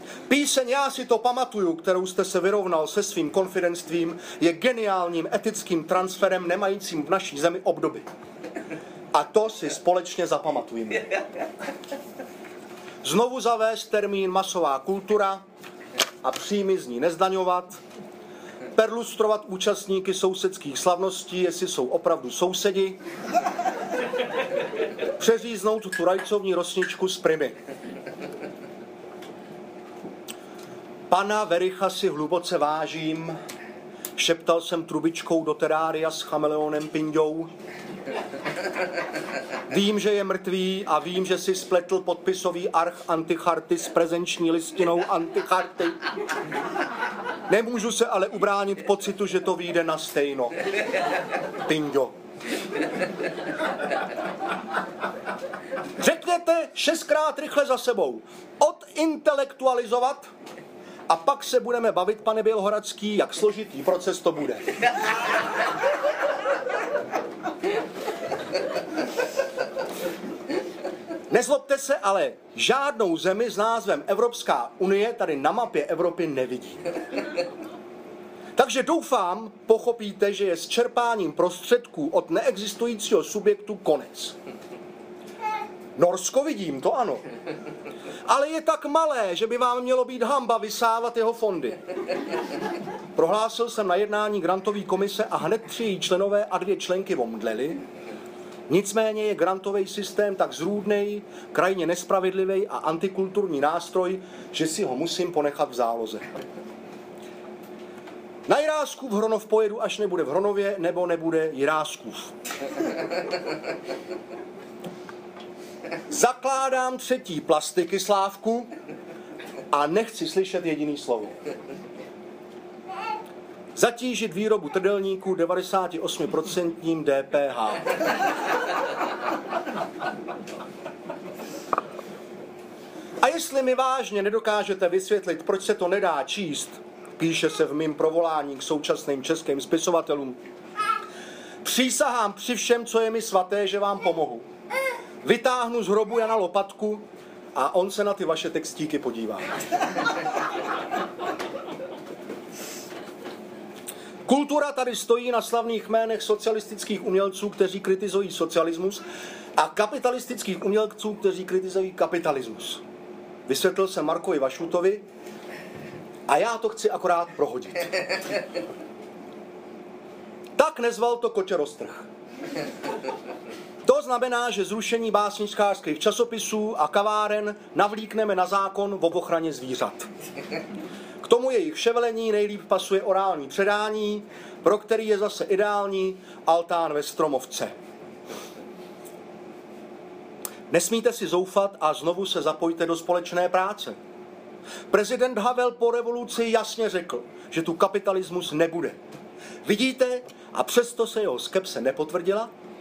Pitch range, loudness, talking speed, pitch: 175-230 Hz, -25 LUFS, 100 wpm, 195 Hz